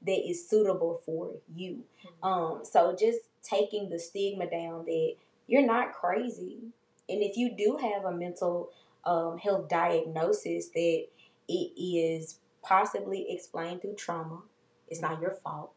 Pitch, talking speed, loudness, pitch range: 175 Hz, 140 wpm, -31 LUFS, 165-205 Hz